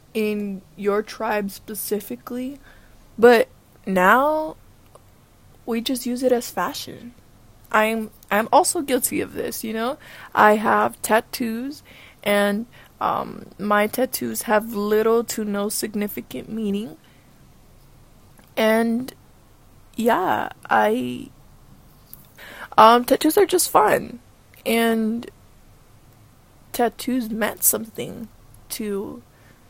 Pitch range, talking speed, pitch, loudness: 205-245 Hz, 95 wpm, 220 Hz, -21 LUFS